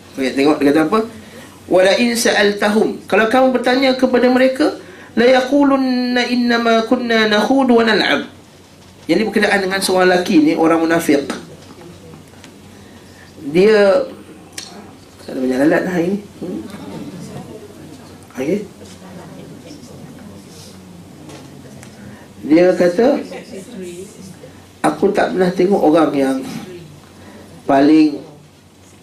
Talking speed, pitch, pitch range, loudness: 95 wpm, 190 Hz, 150-235 Hz, -14 LUFS